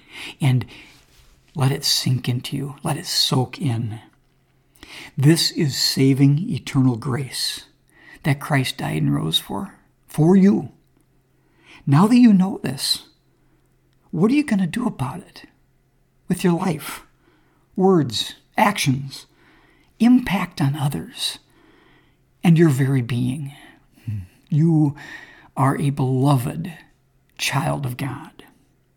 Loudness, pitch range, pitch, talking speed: -20 LUFS, 130-170 Hz, 140 Hz, 115 wpm